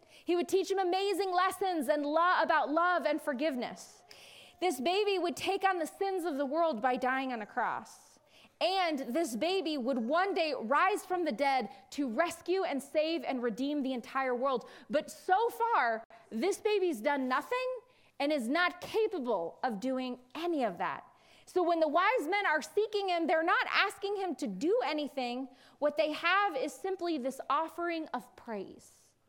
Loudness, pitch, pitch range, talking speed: -32 LUFS, 320 Hz, 265-365 Hz, 180 wpm